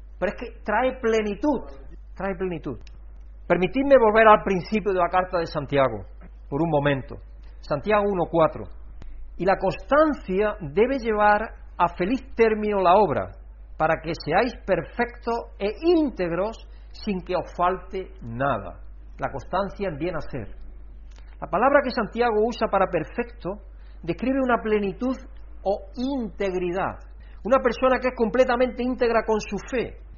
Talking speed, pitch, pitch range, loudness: 135 wpm, 195 Hz, 160-230 Hz, -23 LUFS